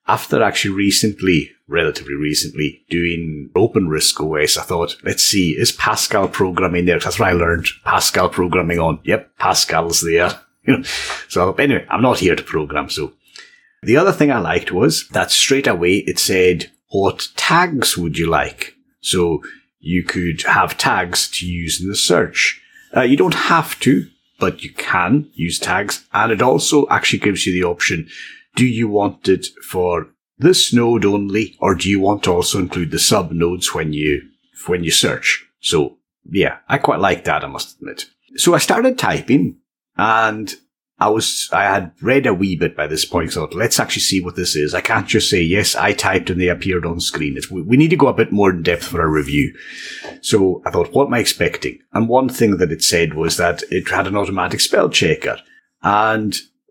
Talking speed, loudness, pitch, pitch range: 195 wpm, -16 LUFS, 95 Hz, 85-105 Hz